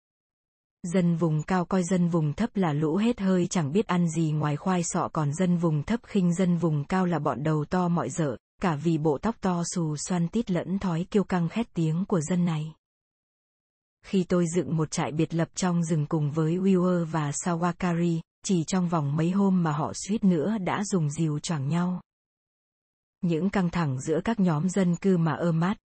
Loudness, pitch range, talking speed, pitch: -26 LUFS, 160-185 Hz, 205 wpm, 175 Hz